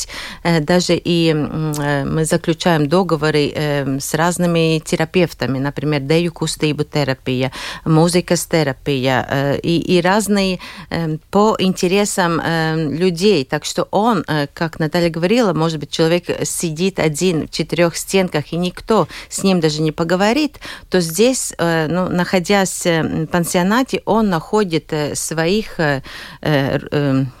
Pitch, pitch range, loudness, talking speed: 165 Hz, 150-185 Hz, -17 LUFS, 110 wpm